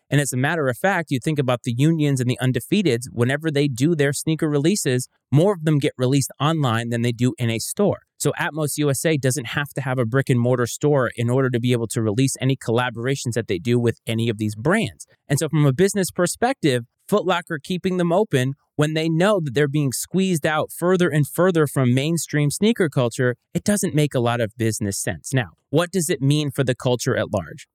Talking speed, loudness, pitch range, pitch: 225 wpm, -21 LUFS, 125-160 Hz, 140 Hz